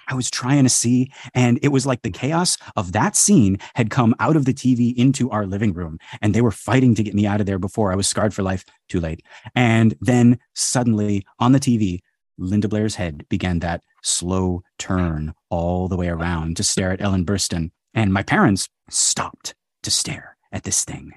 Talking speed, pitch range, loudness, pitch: 205 wpm, 95-120 Hz, -19 LUFS, 105 Hz